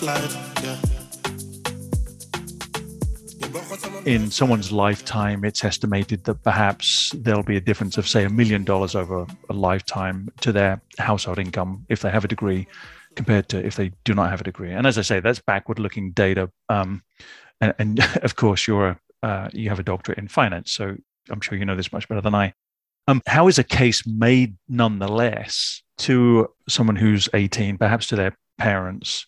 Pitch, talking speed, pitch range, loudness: 105 Hz, 170 wpm, 95-115 Hz, -22 LUFS